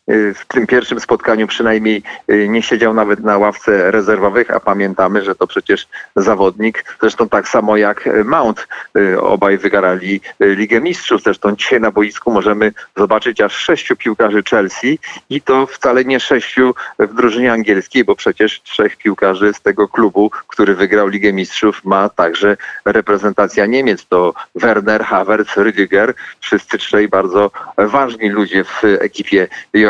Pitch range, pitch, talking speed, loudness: 100-110 Hz, 105 Hz, 140 wpm, -13 LUFS